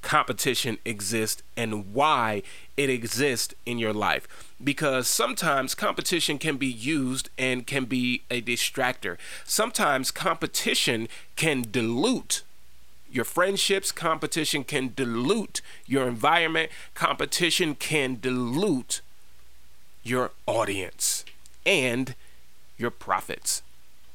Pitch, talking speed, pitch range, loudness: 125 Hz, 95 wpm, 110-145 Hz, -26 LUFS